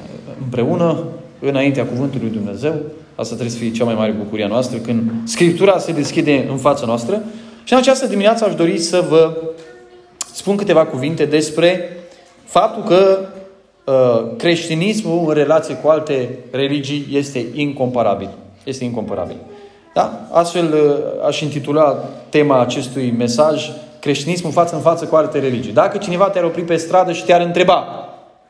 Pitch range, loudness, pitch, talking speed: 130-175 Hz, -16 LUFS, 155 Hz, 150 wpm